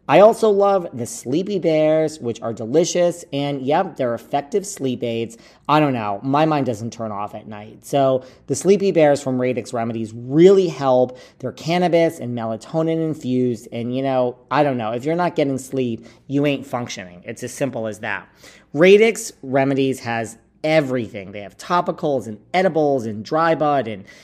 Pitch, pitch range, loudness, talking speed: 135 Hz, 115-160 Hz, -19 LUFS, 175 wpm